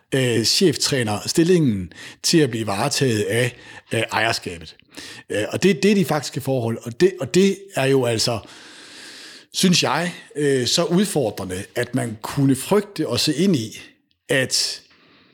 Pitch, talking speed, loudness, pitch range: 135 Hz, 135 wpm, -20 LUFS, 120-170 Hz